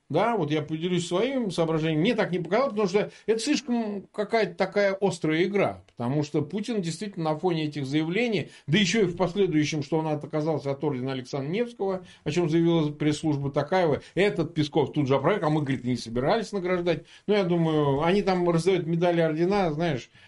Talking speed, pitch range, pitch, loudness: 185 wpm, 150-195 Hz, 170 Hz, -26 LUFS